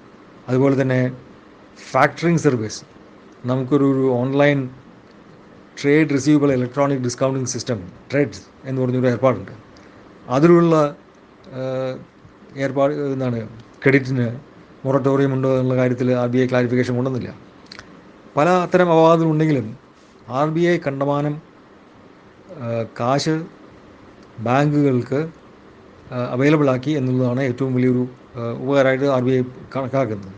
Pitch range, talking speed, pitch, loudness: 125-140 Hz, 90 wpm, 130 Hz, -19 LUFS